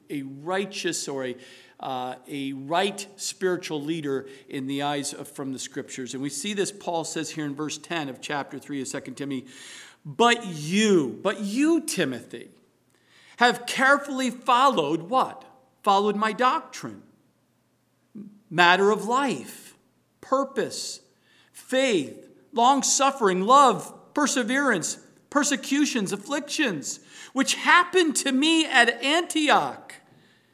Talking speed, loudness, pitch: 120 wpm, -24 LUFS, 200 Hz